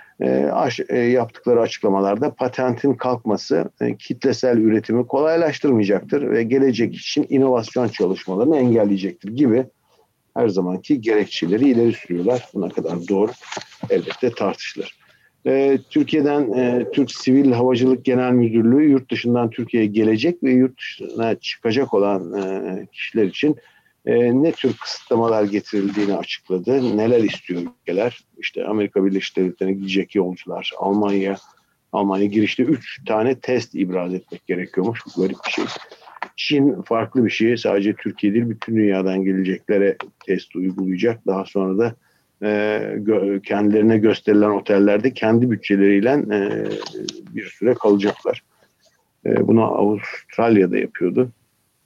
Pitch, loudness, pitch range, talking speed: 110 Hz, -19 LUFS, 100-125 Hz, 115 wpm